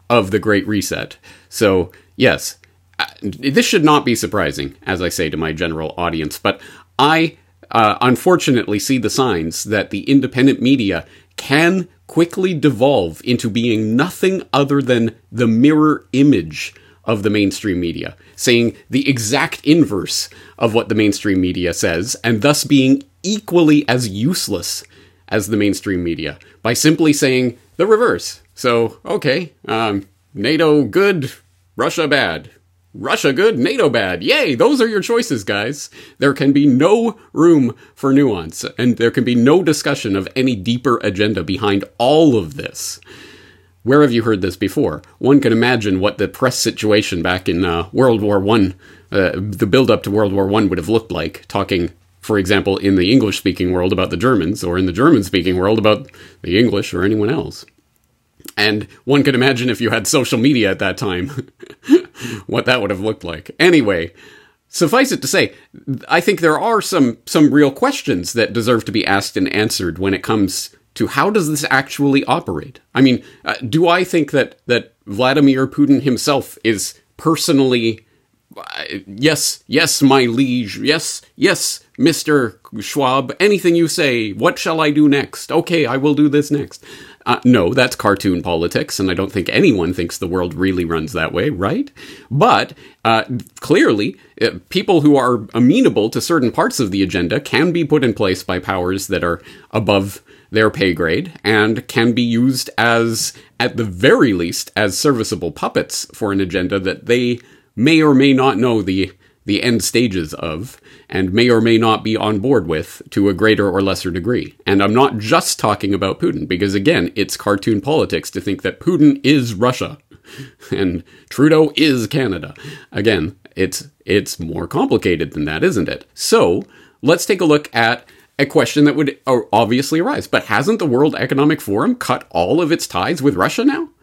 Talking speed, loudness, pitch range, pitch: 170 wpm, -16 LUFS, 100-140 Hz, 120 Hz